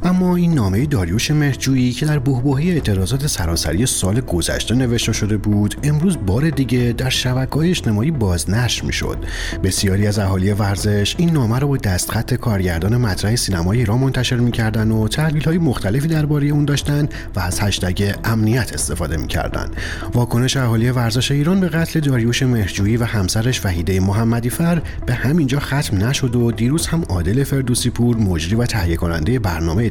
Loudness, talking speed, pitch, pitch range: -18 LUFS, 160 wpm, 115 Hz, 95-135 Hz